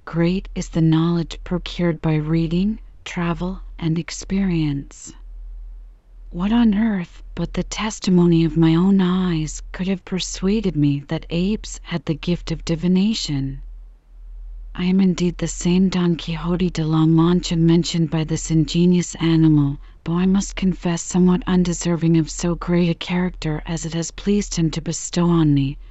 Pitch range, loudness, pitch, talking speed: 160-180 Hz, -20 LUFS, 170 Hz, 155 wpm